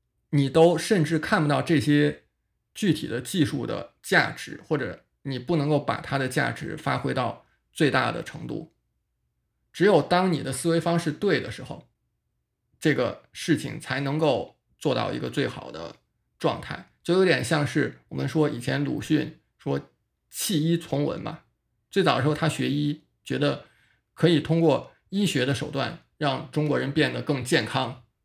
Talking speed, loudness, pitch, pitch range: 235 characters per minute, -25 LUFS, 150 Hz, 140-165 Hz